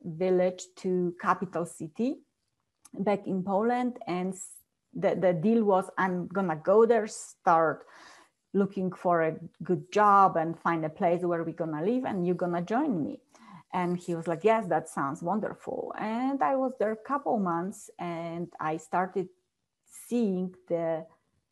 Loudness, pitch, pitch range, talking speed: -29 LUFS, 185 Hz, 170-215 Hz, 155 wpm